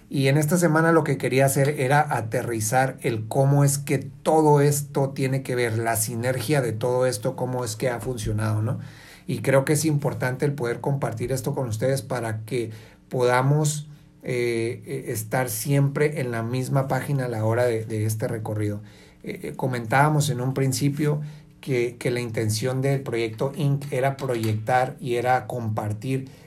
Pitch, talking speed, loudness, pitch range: 130 Hz, 170 wpm, -24 LUFS, 120-140 Hz